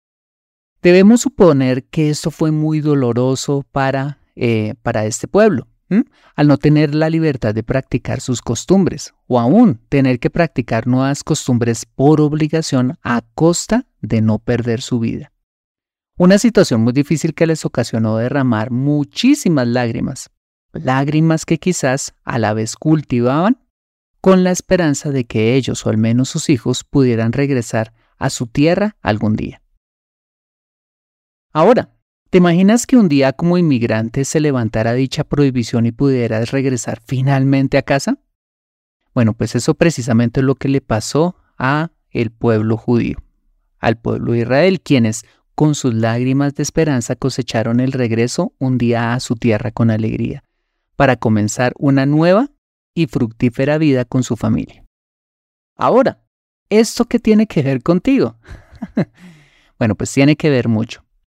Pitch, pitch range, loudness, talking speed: 135 Hz, 120-160 Hz, -15 LUFS, 145 wpm